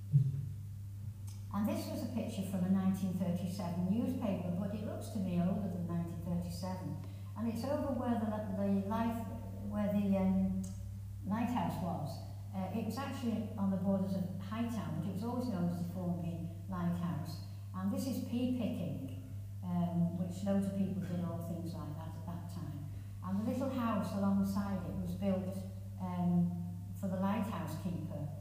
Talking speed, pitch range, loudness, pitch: 165 wpm, 95-105 Hz, -38 LUFS, 100 Hz